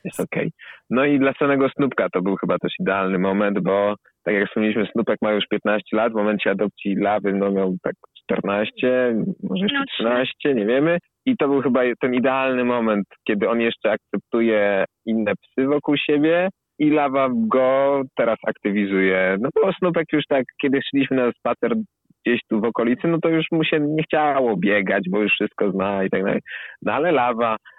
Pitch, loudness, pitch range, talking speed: 120 Hz, -21 LUFS, 105-140 Hz, 185 wpm